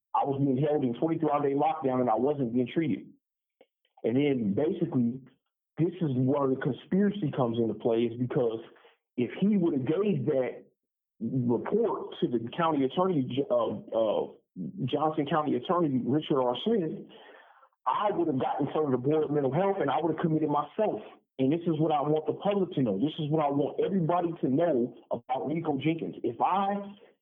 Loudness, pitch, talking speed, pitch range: -29 LUFS, 150 Hz, 185 wpm, 130-170 Hz